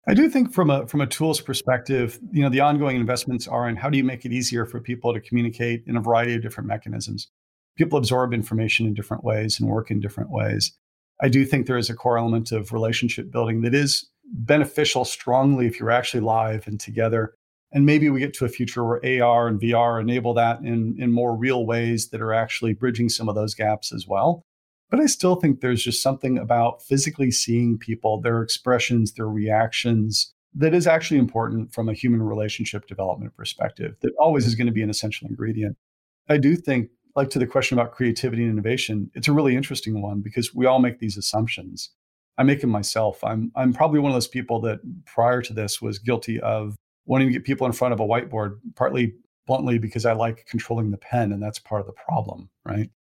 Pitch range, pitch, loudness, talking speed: 110-130 Hz, 120 Hz, -22 LUFS, 215 wpm